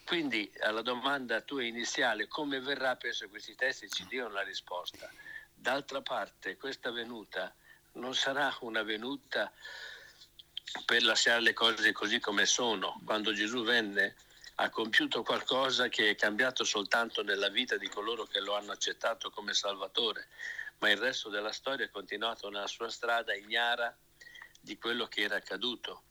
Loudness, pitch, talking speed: -32 LUFS, 140 Hz, 150 wpm